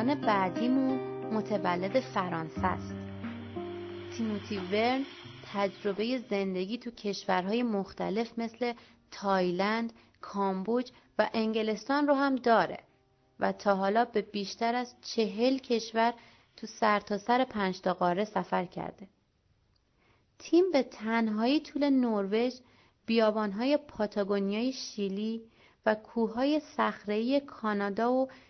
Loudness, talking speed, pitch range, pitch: -31 LUFS, 100 wpm, 200-245 Hz, 220 Hz